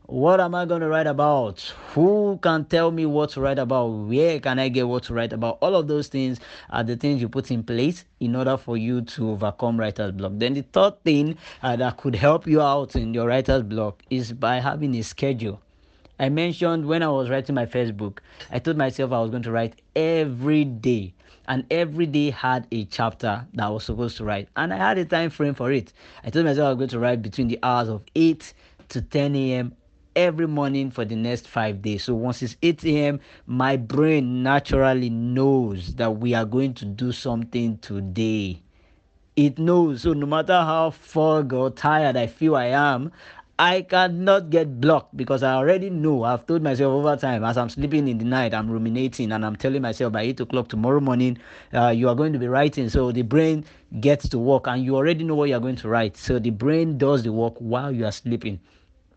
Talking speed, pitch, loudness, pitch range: 220 wpm, 130 Hz, -23 LUFS, 115-150 Hz